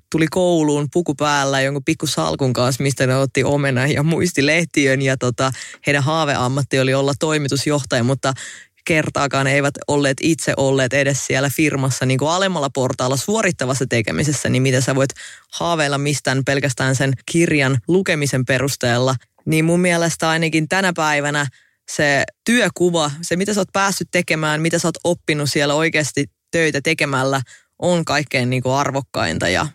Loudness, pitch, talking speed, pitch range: -18 LUFS, 145 Hz, 155 wpm, 135-160 Hz